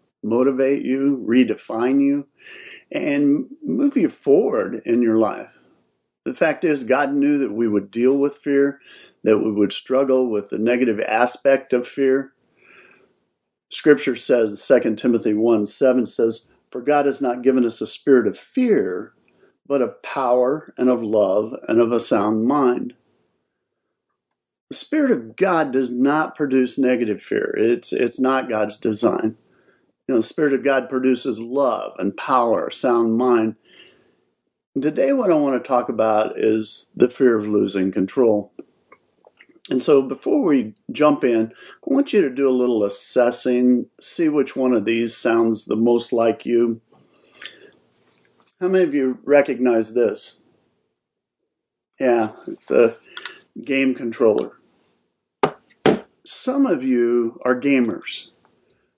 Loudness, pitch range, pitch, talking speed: -19 LUFS, 115-150 Hz, 130 Hz, 140 wpm